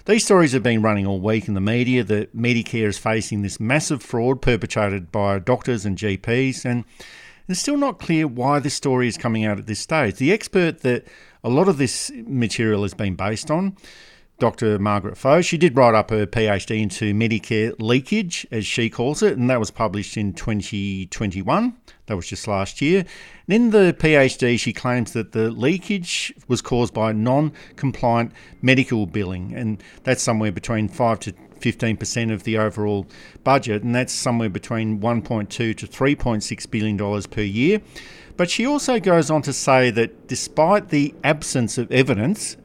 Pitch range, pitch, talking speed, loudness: 105-140 Hz, 120 Hz, 180 wpm, -21 LUFS